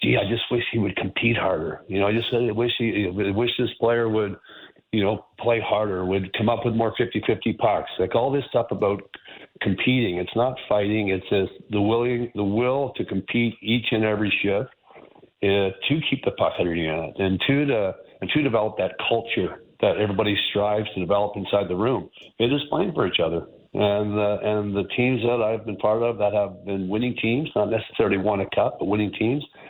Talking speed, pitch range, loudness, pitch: 210 wpm, 100-120 Hz, -23 LUFS, 105 Hz